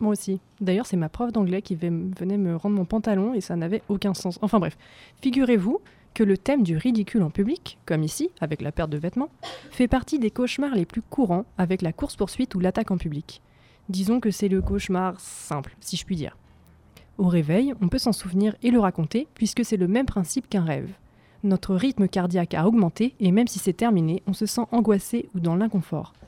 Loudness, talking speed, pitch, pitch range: -25 LUFS, 210 wpm, 195 Hz, 175-225 Hz